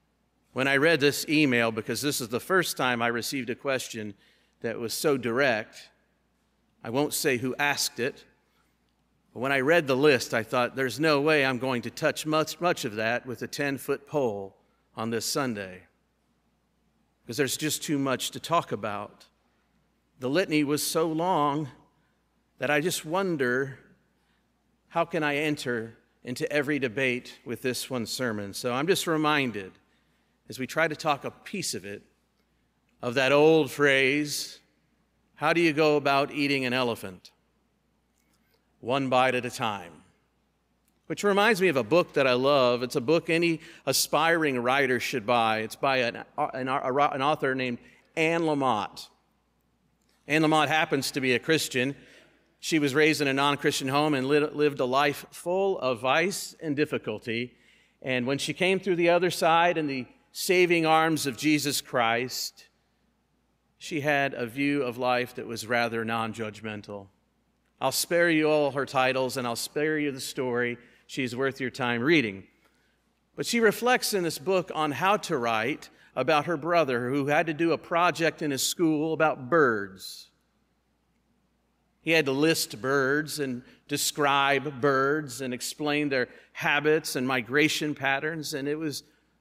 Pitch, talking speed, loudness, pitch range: 140 Hz, 165 wpm, -26 LUFS, 125-155 Hz